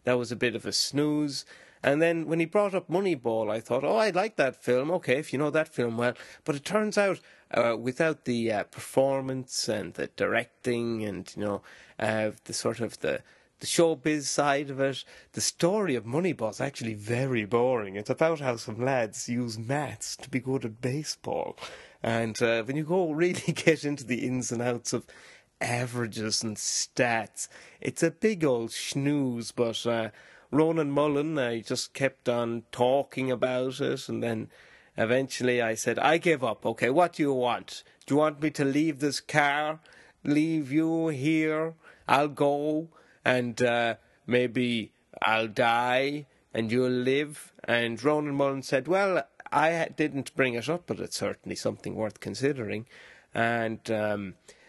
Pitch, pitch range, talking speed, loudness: 130 Hz, 115-150 Hz, 170 wpm, -28 LUFS